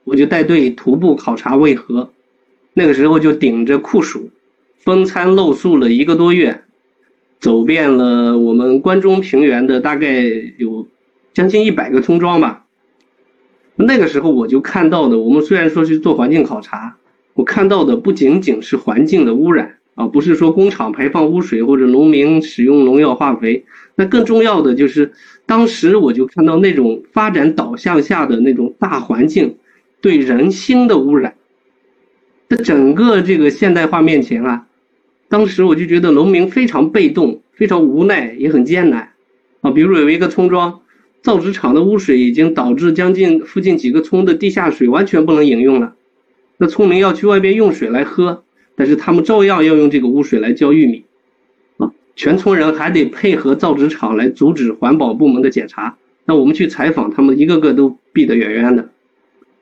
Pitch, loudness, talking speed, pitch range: 160 Hz, -12 LUFS, 270 characters per minute, 130-195 Hz